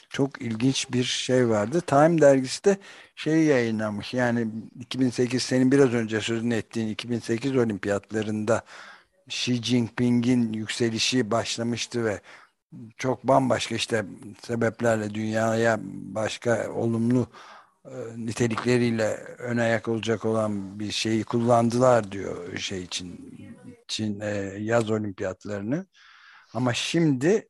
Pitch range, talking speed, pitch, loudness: 110-125 Hz, 105 wpm, 115 Hz, -25 LUFS